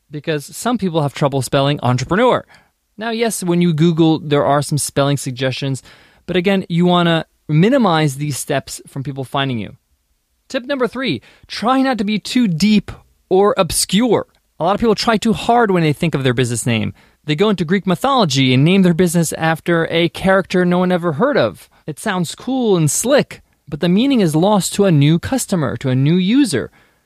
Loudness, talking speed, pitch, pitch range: -16 LUFS, 195 wpm, 175 Hz, 145-205 Hz